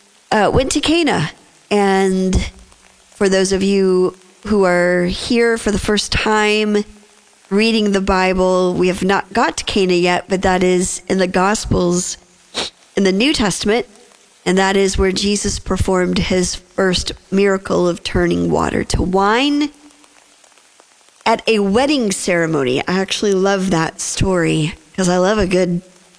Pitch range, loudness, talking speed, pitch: 180-210 Hz, -16 LUFS, 145 wpm, 190 Hz